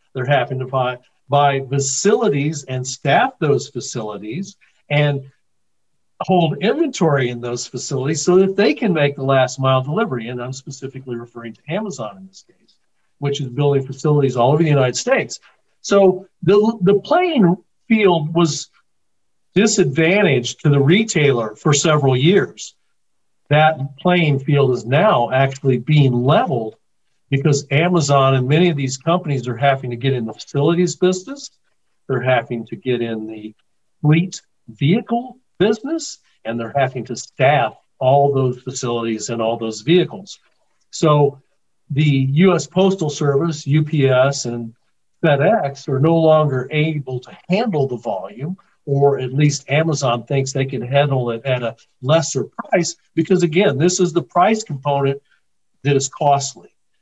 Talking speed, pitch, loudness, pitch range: 145 wpm, 140 Hz, -17 LUFS, 130-170 Hz